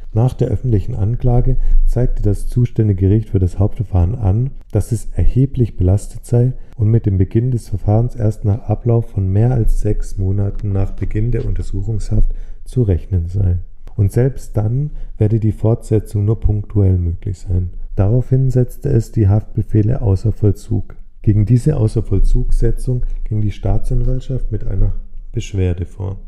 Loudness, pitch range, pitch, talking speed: -18 LUFS, 95-120 Hz, 105 Hz, 150 wpm